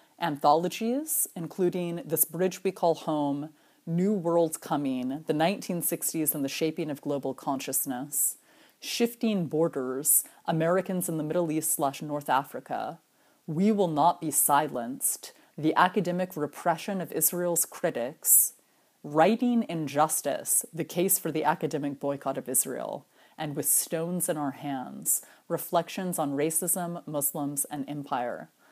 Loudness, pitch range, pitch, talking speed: -27 LUFS, 145-175 Hz, 160 Hz, 125 wpm